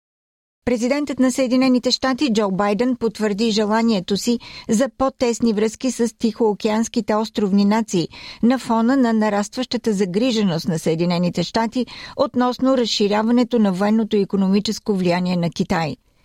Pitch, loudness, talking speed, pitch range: 225 Hz, -19 LUFS, 120 wpm, 205-245 Hz